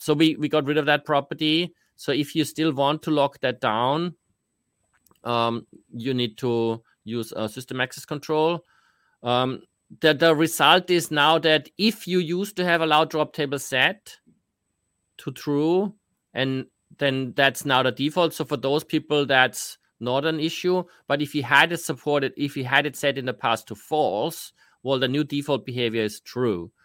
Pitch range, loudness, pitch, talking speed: 130-160 Hz, -23 LUFS, 145 Hz, 185 wpm